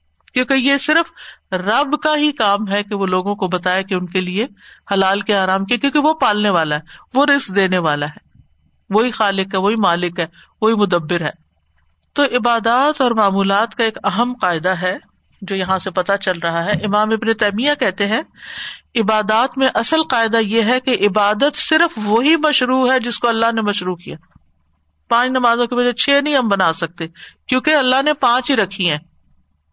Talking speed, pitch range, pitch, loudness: 190 wpm, 185-250 Hz, 210 Hz, -16 LUFS